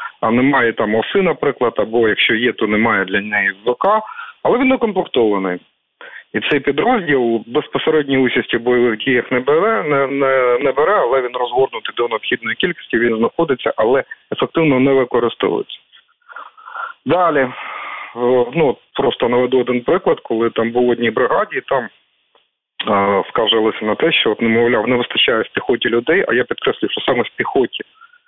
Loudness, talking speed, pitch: -16 LUFS, 155 wpm, 135 Hz